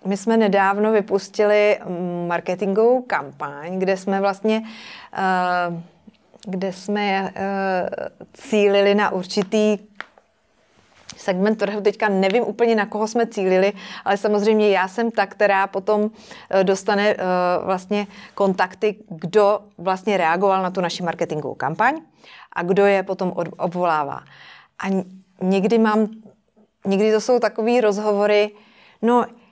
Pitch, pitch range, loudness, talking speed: 200 Hz, 190-215 Hz, -20 LUFS, 110 wpm